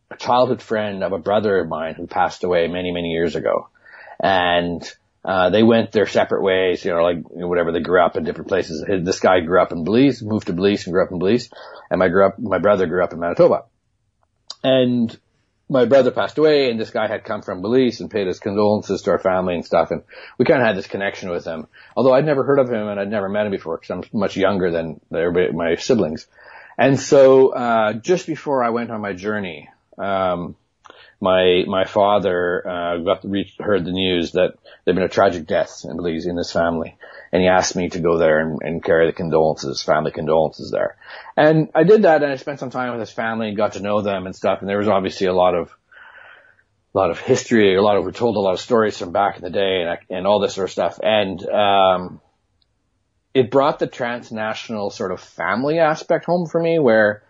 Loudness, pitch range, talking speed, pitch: -19 LUFS, 90-125 Hz, 230 wpm, 105 Hz